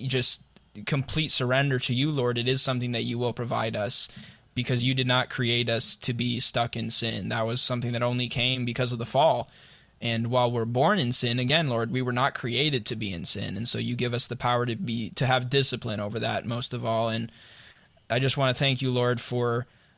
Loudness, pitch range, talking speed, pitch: -26 LUFS, 115-130 Hz, 230 wpm, 120 Hz